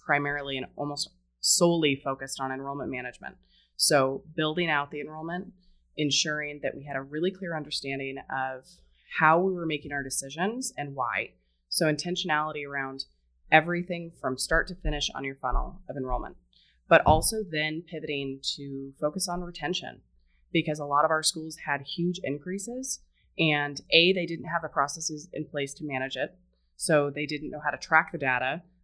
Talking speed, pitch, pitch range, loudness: 170 wpm, 145 Hz, 135-165 Hz, -28 LUFS